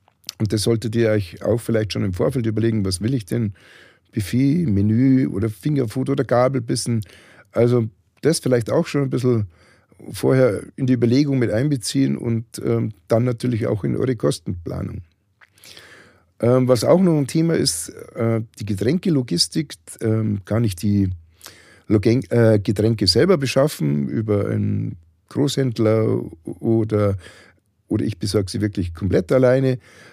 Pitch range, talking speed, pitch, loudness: 105-130 Hz, 145 wpm, 115 Hz, -20 LUFS